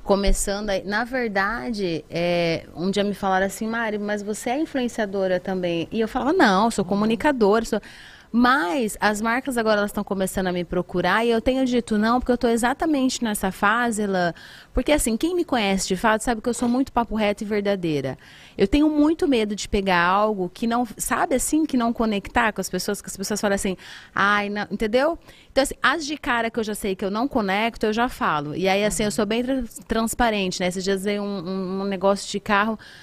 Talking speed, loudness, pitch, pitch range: 210 wpm, -22 LUFS, 215 Hz, 195-240 Hz